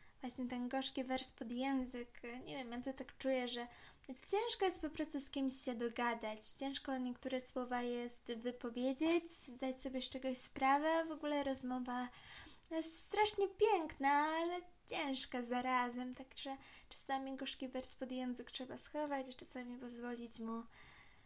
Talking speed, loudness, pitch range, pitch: 145 wpm, -40 LUFS, 245-280 Hz, 260 Hz